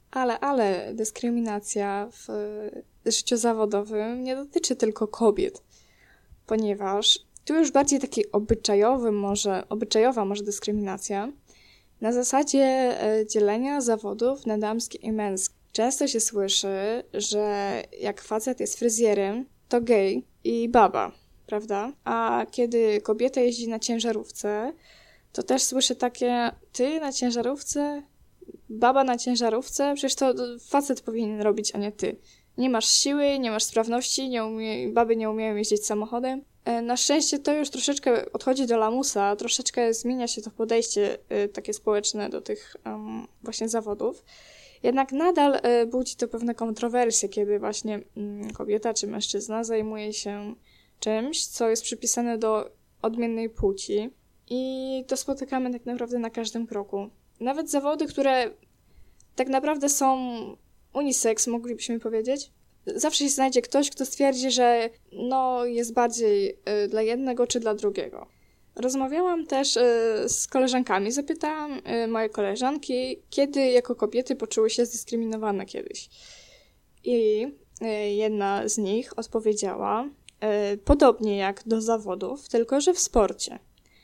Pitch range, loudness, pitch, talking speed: 215-260 Hz, -25 LUFS, 235 Hz, 125 wpm